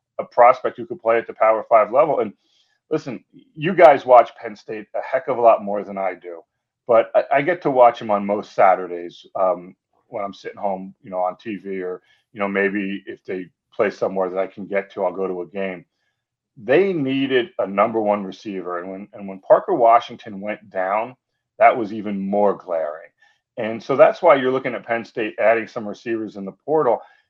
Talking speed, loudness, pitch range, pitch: 210 wpm, -19 LUFS, 95-115 Hz, 100 Hz